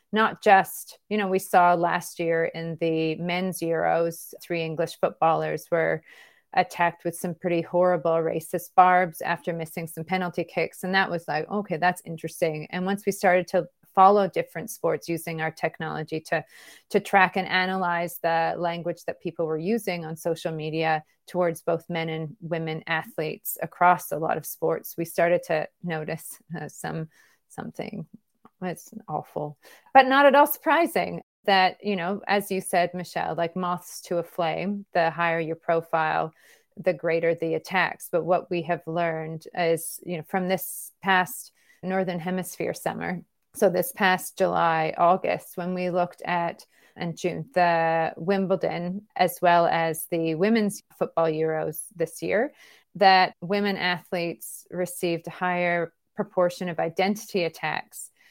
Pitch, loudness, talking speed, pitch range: 175 Hz, -25 LUFS, 155 wpm, 165-185 Hz